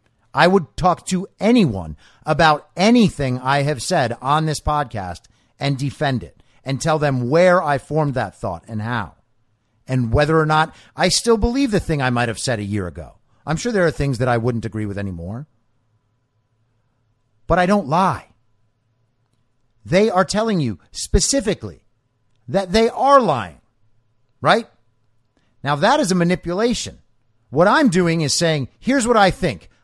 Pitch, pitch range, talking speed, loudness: 130 Hz, 115-175 Hz, 165 wpm, -18 LUFS